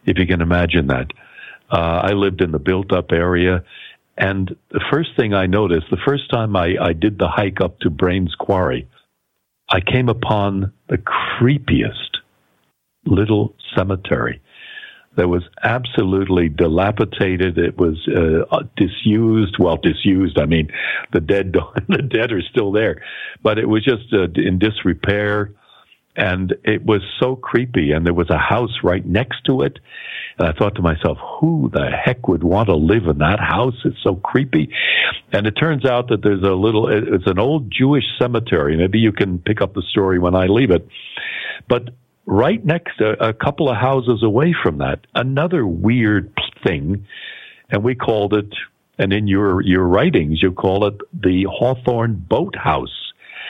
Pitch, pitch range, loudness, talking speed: 100 Hz, 90-115 Hz, -17 LUFS, 165 wpm